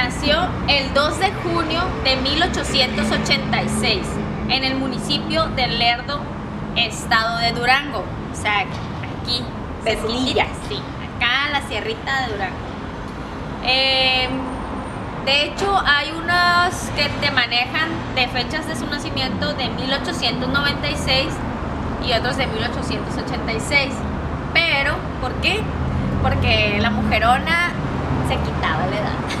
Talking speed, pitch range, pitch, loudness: 110 wpm, 230-285 Hz, 255 Hz, -19 LUFS